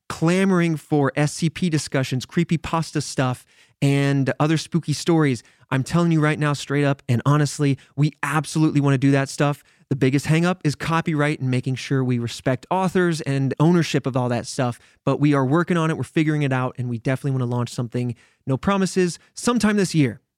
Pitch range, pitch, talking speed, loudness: 130-160 Hz, 145 Hz, 195 wpm, -21 LUFS